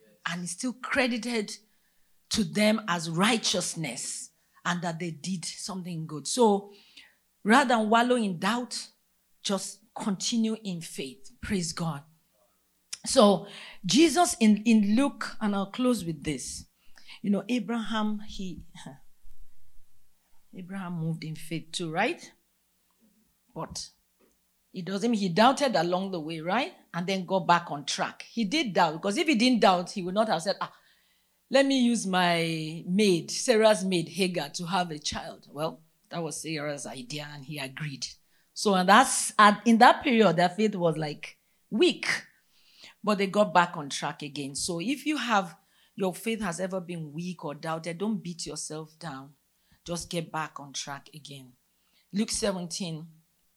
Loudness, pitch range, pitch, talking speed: -27 LUFS, 160-215 Hz, 185 Hz, 155 wpm